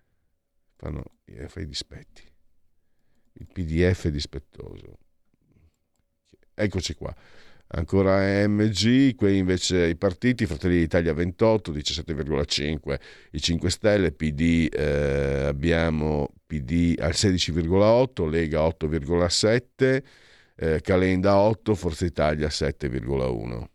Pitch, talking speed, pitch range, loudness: 85 Hz, 90 wpm, 80-95 Hz, -24 LUFS